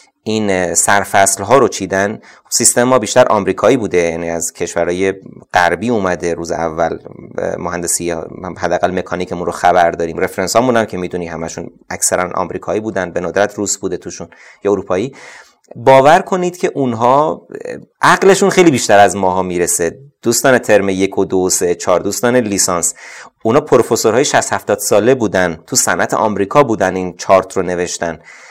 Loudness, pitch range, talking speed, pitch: -14 LUFS, 90-110 Hz, 150 wpm, 95 Hz